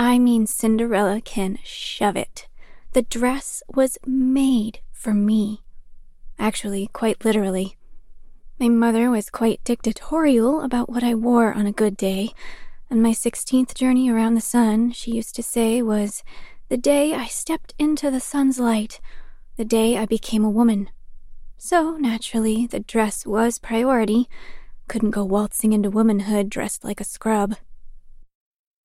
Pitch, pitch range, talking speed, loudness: 230 Hz, 215-250 Hz, 145 wpm, -21 LUFS